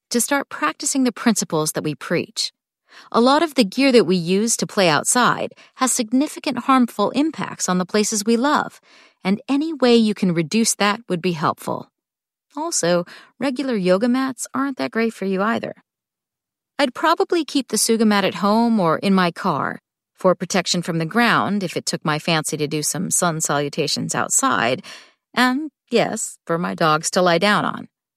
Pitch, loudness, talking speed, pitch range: 210 Hz, -19 LUFS, 180 wpm, 180-255 Hz